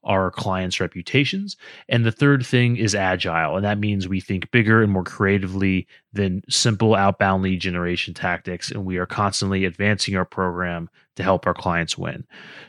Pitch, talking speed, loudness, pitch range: 95 Hz, 170 wpm, -21 LUFS, 95-110 Hz